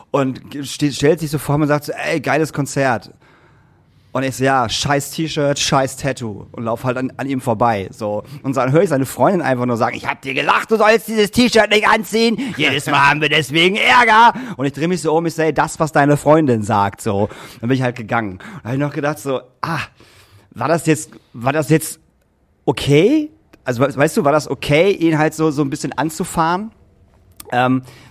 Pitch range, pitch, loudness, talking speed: 125-160 Hz, 145 Hz, -16 LUFS, 215 wpm